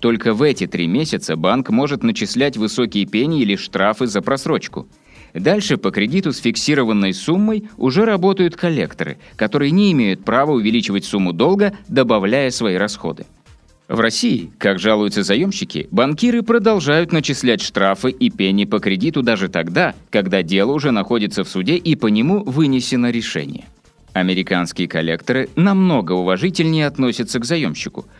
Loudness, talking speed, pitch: -17 LUFS, 140 wpm, 130 Hz